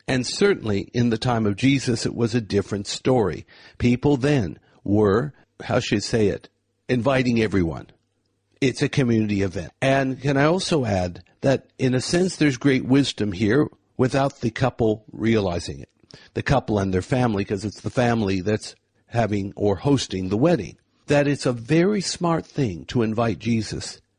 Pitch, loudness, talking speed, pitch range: 120 Hz, -22 LUFS, 170 wpm, 105-135 Hz